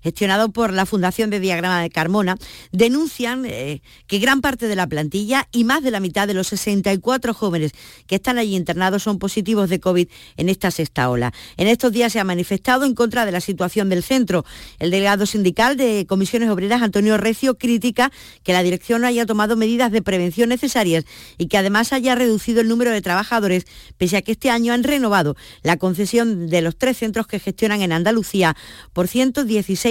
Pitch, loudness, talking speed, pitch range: 205 Hz, -19 LUFS, 195 wpm, 185-235 Hz